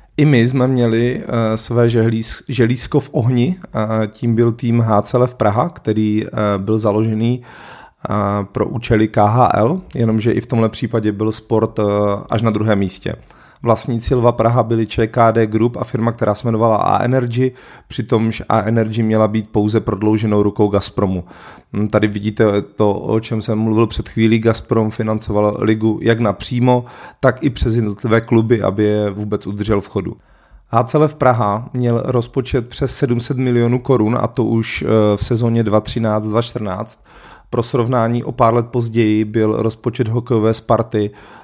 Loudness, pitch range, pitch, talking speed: -16 LUFS, 110-120 Hz, 115 Hz, 150 wpm